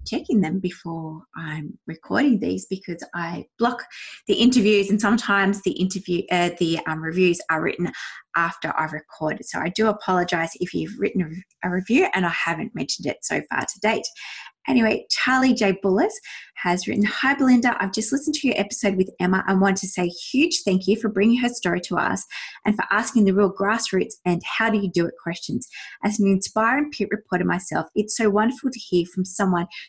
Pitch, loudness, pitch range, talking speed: 195 Hz, -22 LUFS, 175-225 Hz, 195 wpm